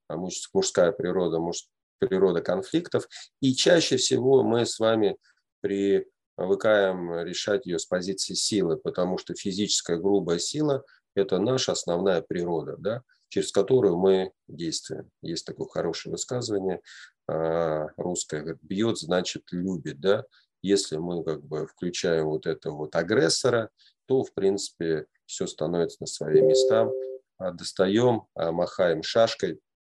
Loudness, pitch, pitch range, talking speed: -26 LUFS, 95 Hz, 85-115 Hz, 120 wpm